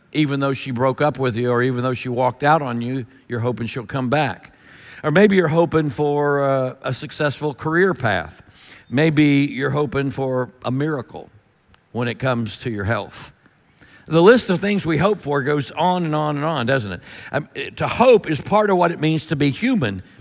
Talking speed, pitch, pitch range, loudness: 200 wpm, 140 Hz, 125-155 Hz, -19 LUFS